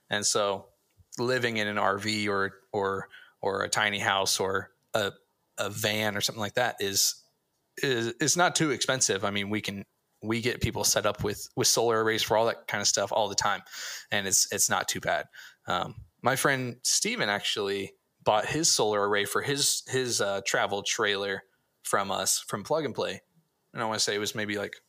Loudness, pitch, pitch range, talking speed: -27 LUFS, 105 Hz, 100-125 Hz, 200 wpm